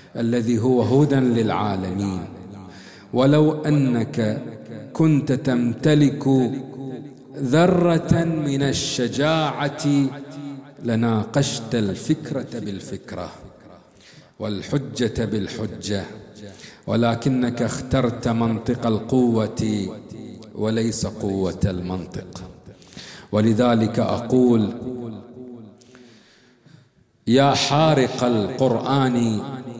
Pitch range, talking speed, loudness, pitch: 110-135 Hz, 55 wpm, -21 LUFS, 120 Hz